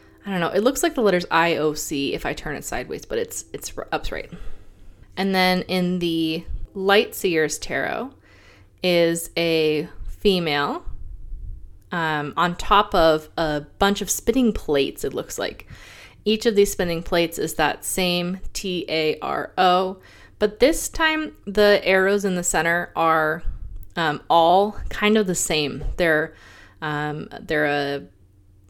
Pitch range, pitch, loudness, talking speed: 155-200 Hz, 170 Hz, -22 LUFS, 145 wpm